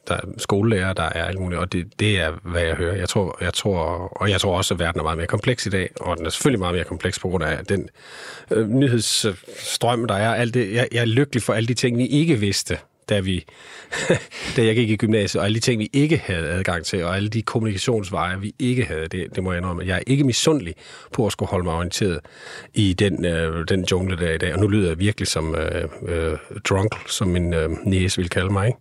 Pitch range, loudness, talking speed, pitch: 90-115 Hz, -22 LUFS, 250 wpm, 100 Hz